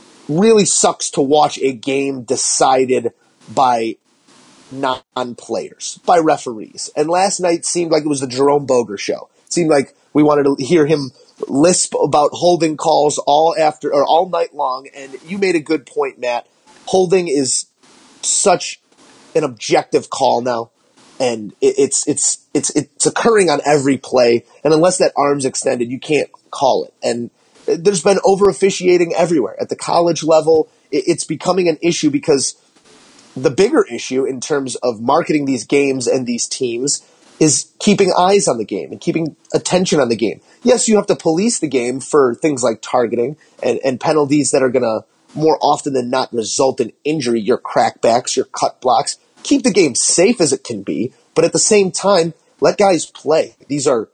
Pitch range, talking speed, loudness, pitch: 140-190 Hz, 175 wpm, -15 LUFS, 160 Hz